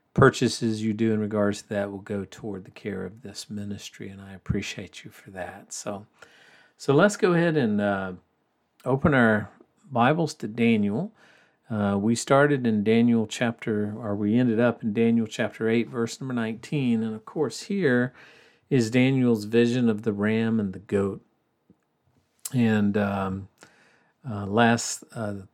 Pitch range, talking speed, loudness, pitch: 105-125 Hz, 160 wpm, -25 LUFS, 115 Hz